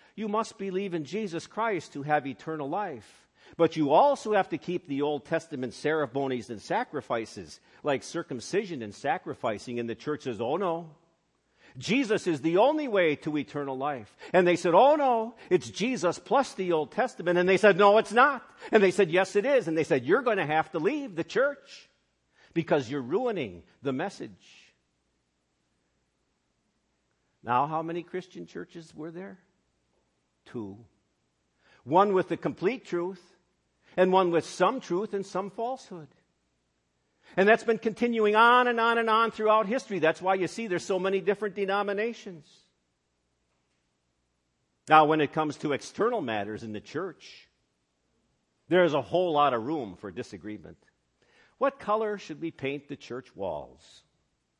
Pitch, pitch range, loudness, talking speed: 165 Hz, 125-200 Hz, -27 LUFS, 160 wpm